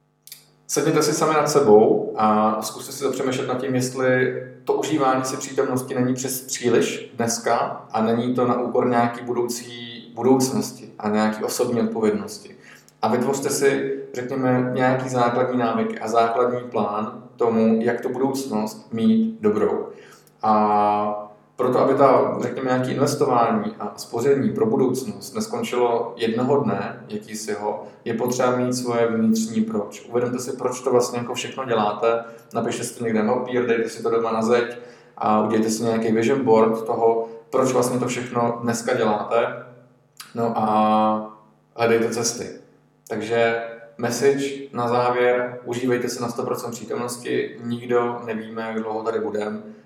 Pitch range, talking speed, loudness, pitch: 115-130 Hz, 150 wpm, -22 LUFS, 120 Hz